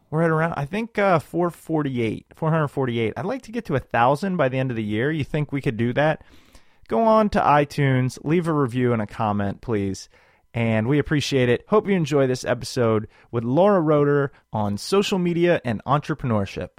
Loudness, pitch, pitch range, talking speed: -22 LUFS, 140 Hz, 120-165 Hz, 205 wpm